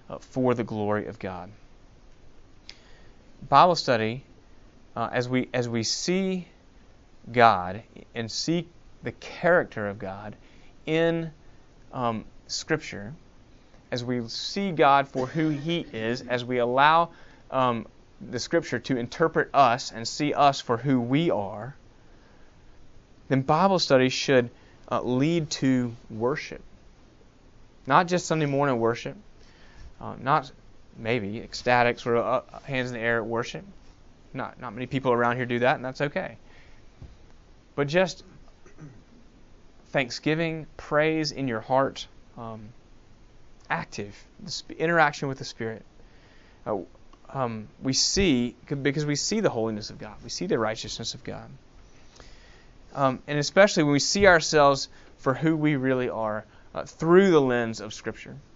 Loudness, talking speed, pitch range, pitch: -25 LUFS, 135 wpm, 110-145 Hz, 125 Hz